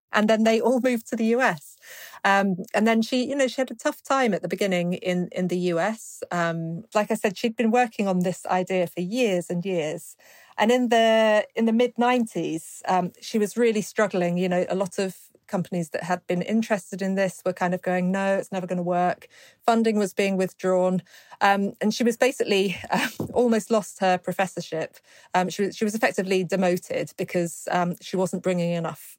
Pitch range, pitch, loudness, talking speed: 180-225 Hz, 195 Hz, -24 LUFS, 210 wpm